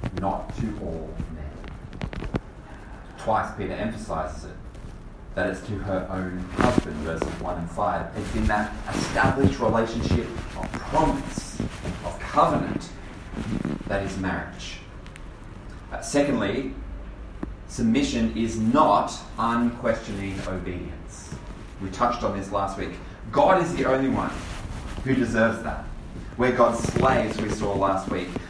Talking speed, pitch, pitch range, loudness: 120 wpm, 95 Hz, 90-110 Hz, -26 LUFS